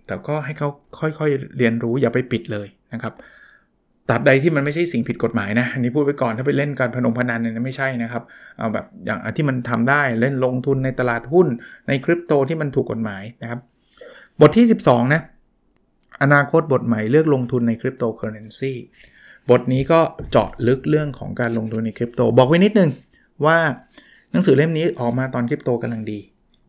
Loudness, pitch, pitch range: -19 LUFS, 130 Hz, 120-145 Hz